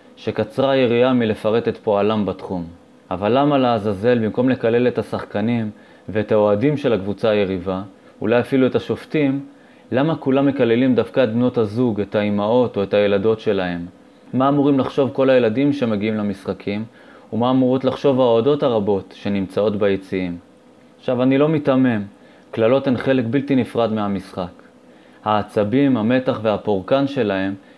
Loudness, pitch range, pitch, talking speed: -19 LUFS, 100-130 Hz, 115 Hz, 135 wpm